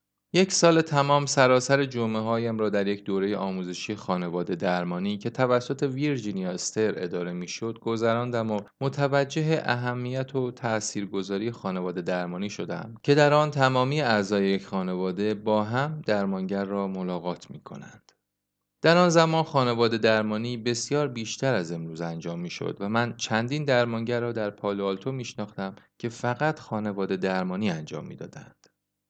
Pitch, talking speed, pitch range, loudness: 110 Hz, 140 wpm, 95-130 Hz, -26 LUFS